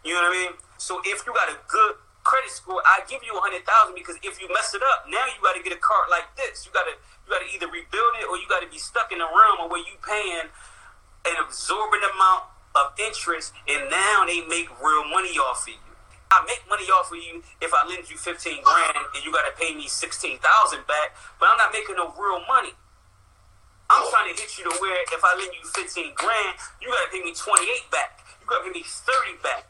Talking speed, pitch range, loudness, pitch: 255 wpm, 175-265 Hz, -22 LUFS, 190 Hz